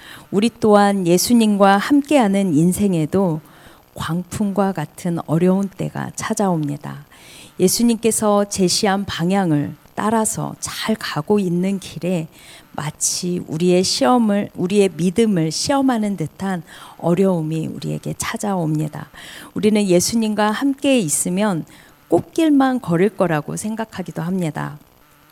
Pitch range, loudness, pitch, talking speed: 160-210 Hz, -18 LUFS, 185 Hz, 270 characters per minute